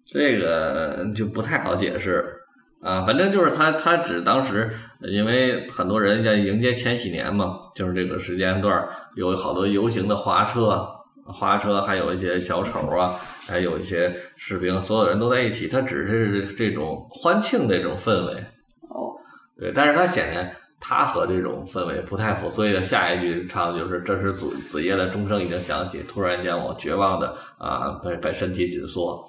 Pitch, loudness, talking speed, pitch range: 100 Hz, -23 LUFS, 265 characters per minute, 90-115 Hz